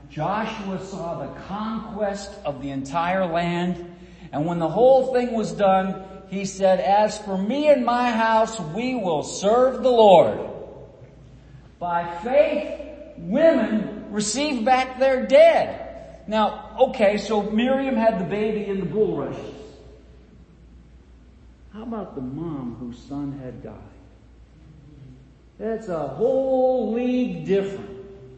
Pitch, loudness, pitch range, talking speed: 200 Hz, -22 LUFS, 160-240 Hz, 125 wpm